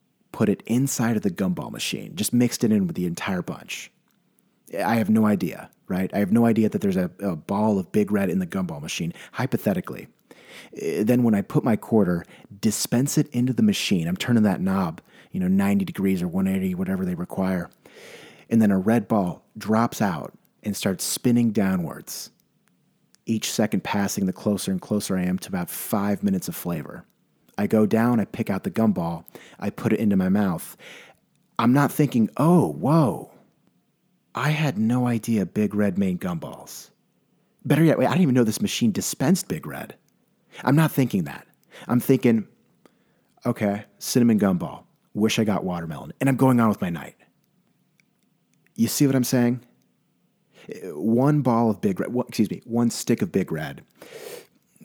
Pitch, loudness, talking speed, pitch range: 120 Hz, -23 LUFS, 180 wpm, 105-170 Hz